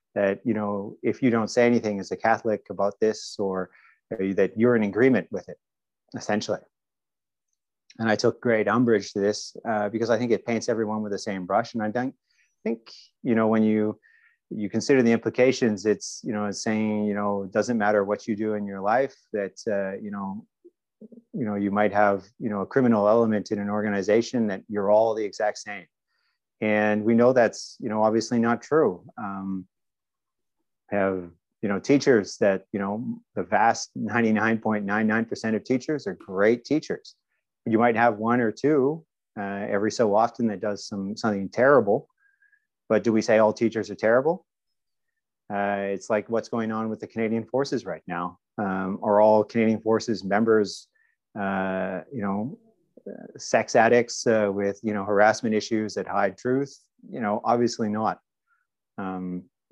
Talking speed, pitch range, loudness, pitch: 175 wpm, 100-120 Hz, -24 LUFS, 110 Hz